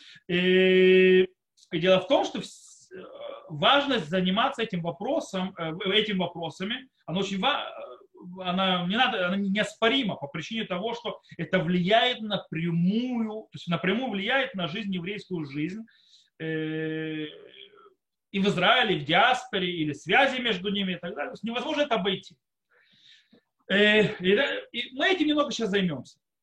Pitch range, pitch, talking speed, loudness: 180-230 Hz, 195 Hz, 125 wpm, -26 LUFS